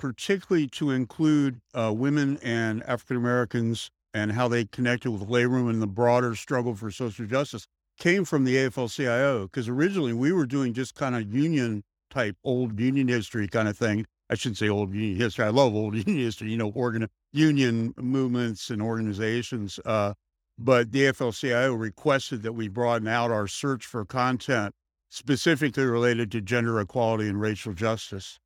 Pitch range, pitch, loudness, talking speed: 110-130 Hz, 120 Hz, -26 LUFS, 170 wpm